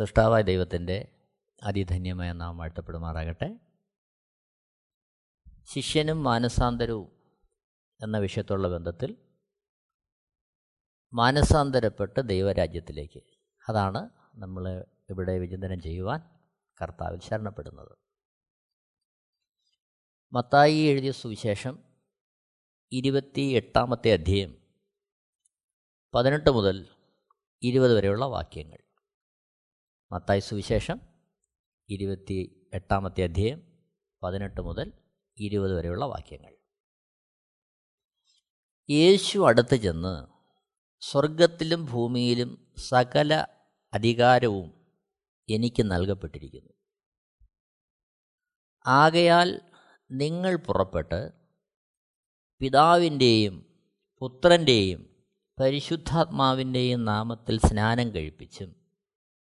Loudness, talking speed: -25 LUFS, 60 wpm